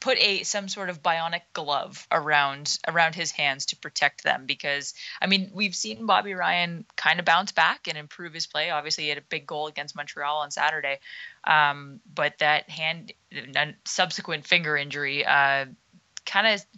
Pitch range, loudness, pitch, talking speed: 145-180 Hz, -25 LUFS, 160 Hz, 180 wpm